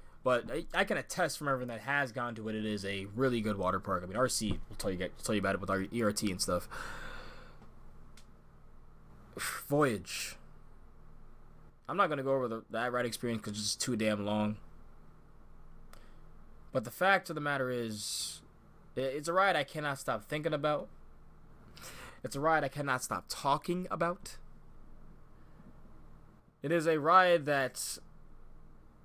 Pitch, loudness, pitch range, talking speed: 130 Hz, -33 LUFS, 105-150 Hz, 160 wpm